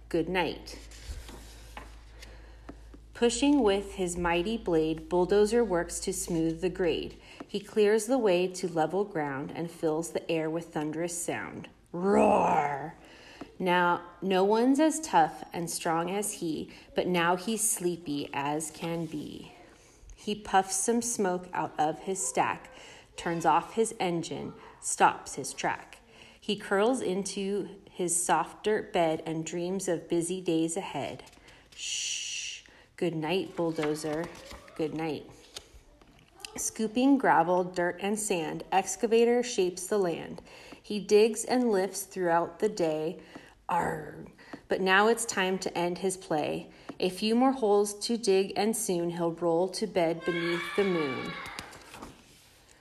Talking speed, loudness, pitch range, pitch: 135 wpm, -29 LUFS, 170-205 Hz, 185 Hz